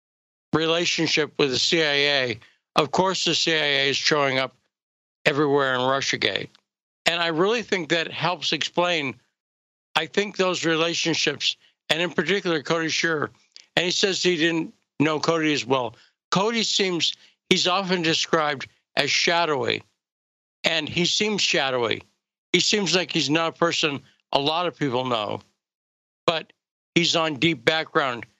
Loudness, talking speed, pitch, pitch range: -22 LUFS, 140 wpm, 160 Hz, 140-175 Hz